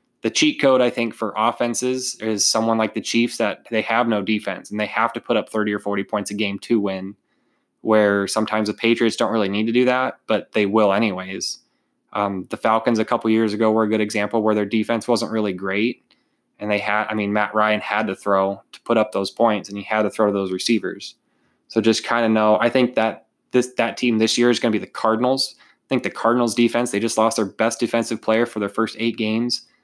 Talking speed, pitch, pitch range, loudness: 240 wpm, 110 Hz, 105-115 Hz, -20 LUFS